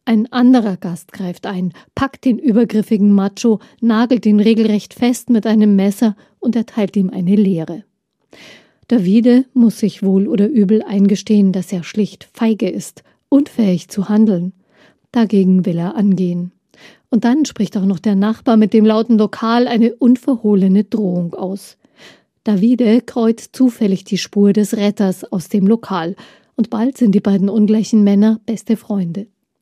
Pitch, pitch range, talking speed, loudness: 210 Hz, 195-230 Hz, 150 wpm, -15 LUFS